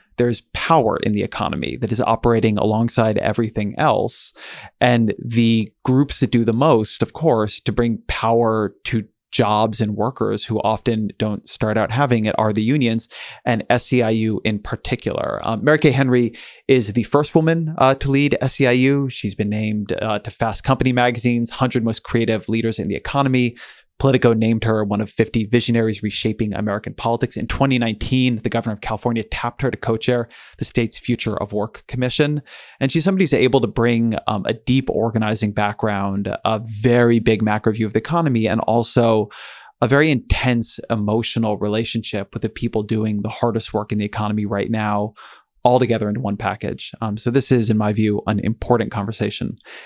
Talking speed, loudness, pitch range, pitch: 180 wpm, -19 LUFS, 110-125 Hz, 115 Hz